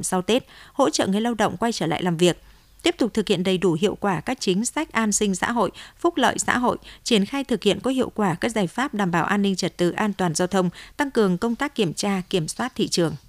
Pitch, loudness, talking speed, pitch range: 205 Hz, -23 LUFS, 275 wpm, 180-235 Hz